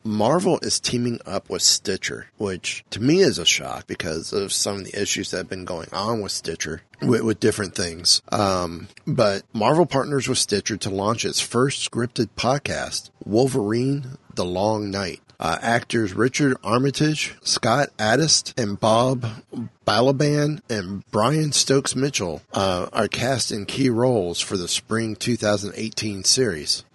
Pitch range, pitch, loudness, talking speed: 105-130 Hz, 115 Hz, -22 LUFS, 150 wpm